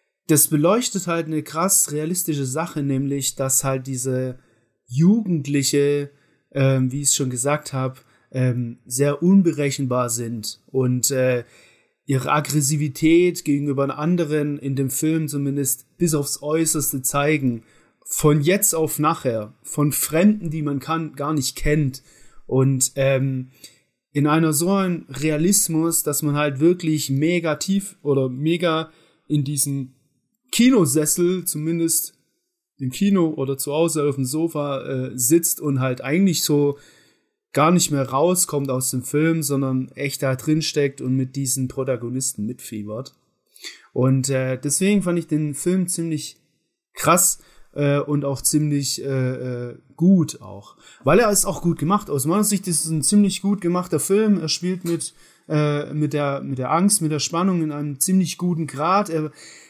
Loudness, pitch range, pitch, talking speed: -20 LUFS, 135-165 Hz, 150 Hz, 150 wpm